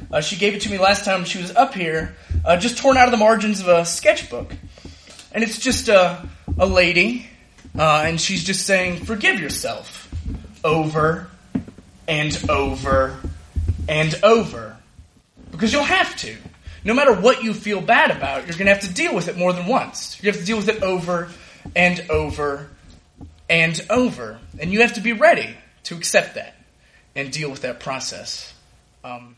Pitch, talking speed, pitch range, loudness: 175 Hz, 180 wpm, 140-210 Hz, -19 LUFS